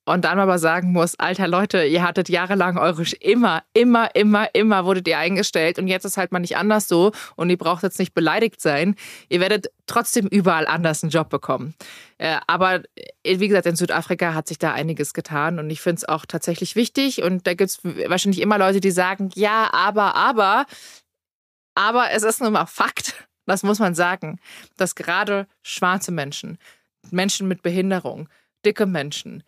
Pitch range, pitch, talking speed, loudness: 170-200 Hz, 185 Hz, 185 wpm, -20 LUFS